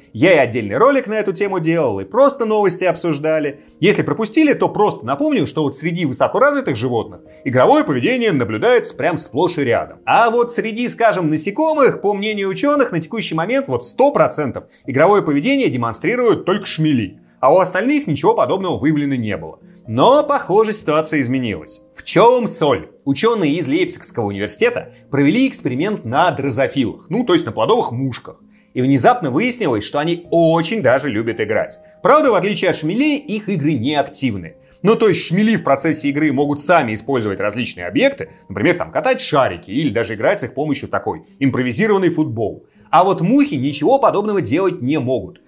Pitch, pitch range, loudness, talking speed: 170 Hz, 140-225 Hz, -16 LUFS, 170 wpm